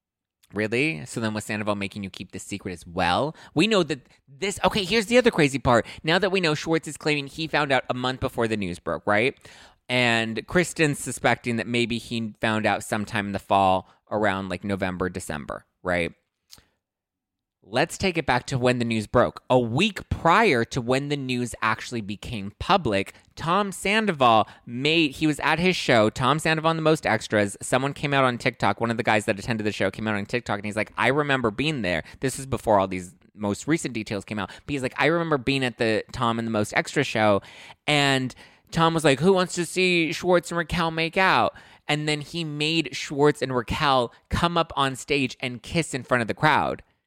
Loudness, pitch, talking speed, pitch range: -24 LUFS, 130 Hz, 215 wpm, 110-155 Hz